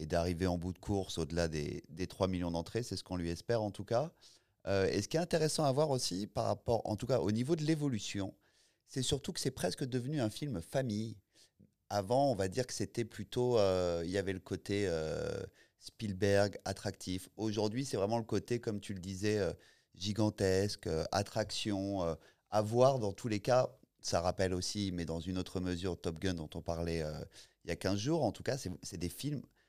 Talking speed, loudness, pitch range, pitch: 220 wpm, -36 LUFS, 90-120 Hz, 100 Hz